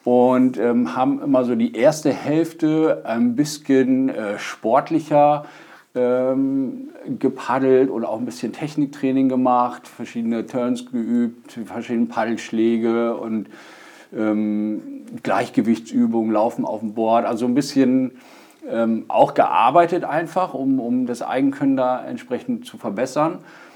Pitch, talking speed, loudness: 130 Hz, 120 wpm, -20 LUFS